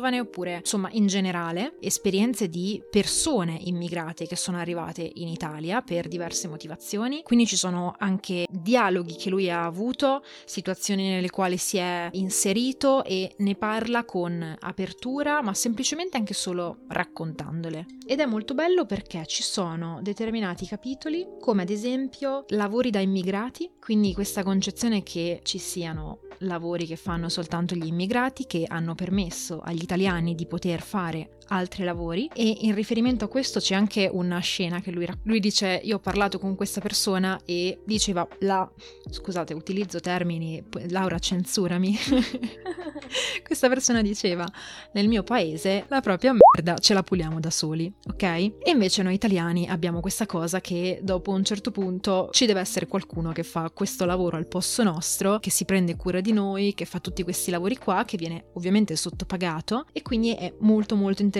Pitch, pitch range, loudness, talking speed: 190 Hz, 175-215 Hz, -26 LUFS, 160 wpm